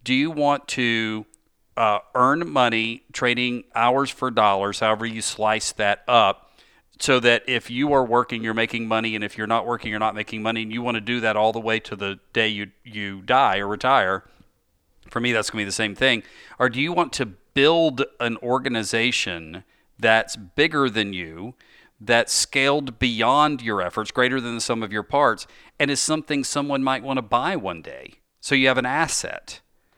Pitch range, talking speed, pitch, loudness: 110-130 Hz, 200 wpm, 115 Hz, -22 LUFS